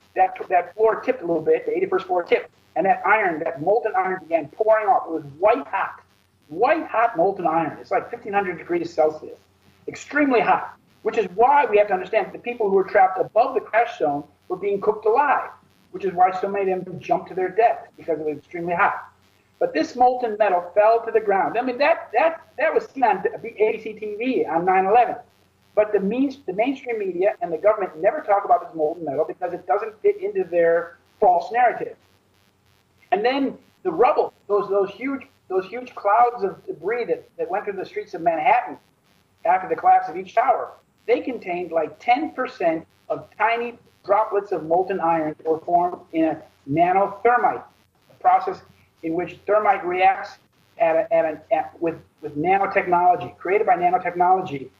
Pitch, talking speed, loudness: 225 Hz, 190 wpm, -22 LUFS